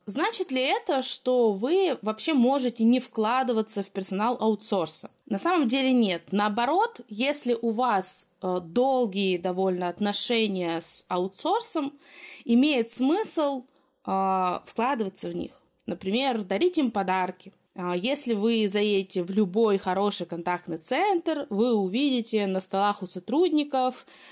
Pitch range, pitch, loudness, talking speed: 190-265 Hz, 225 Hz, -26 LUFS, 120 wpm